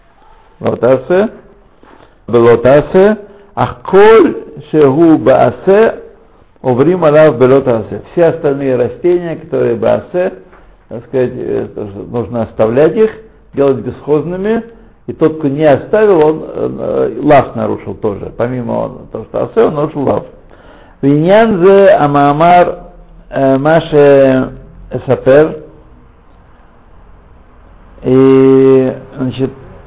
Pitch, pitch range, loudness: 140 Hz, 120-175 Hz, -10 LUFS